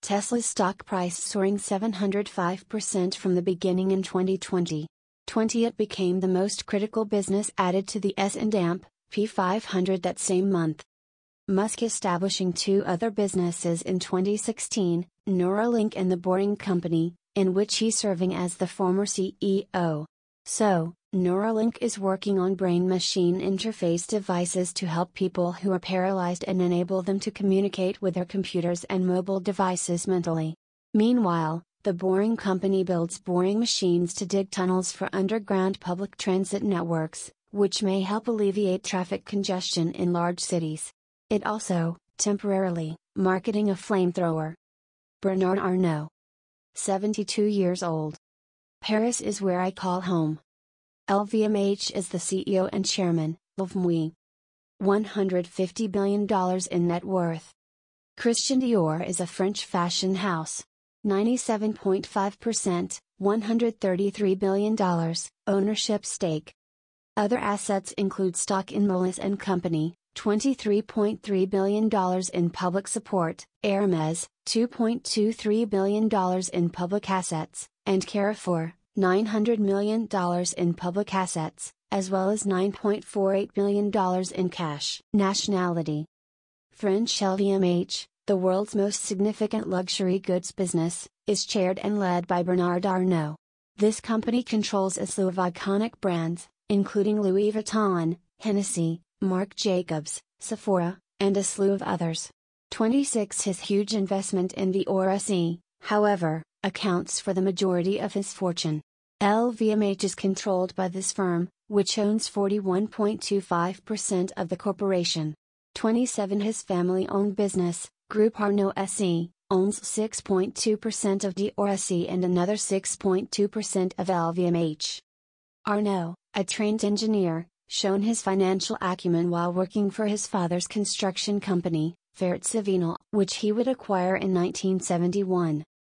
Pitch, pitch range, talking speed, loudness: 190 Hz, 180-205 Hz, 125 wpm, -26 LUFS